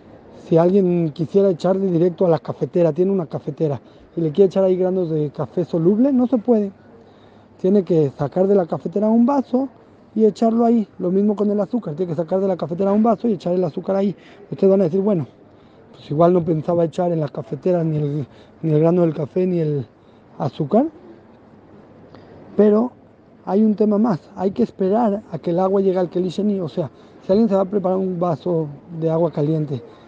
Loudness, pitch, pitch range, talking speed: -19 LUFS, 180 Hz, 155-200 Hz, 205 wpm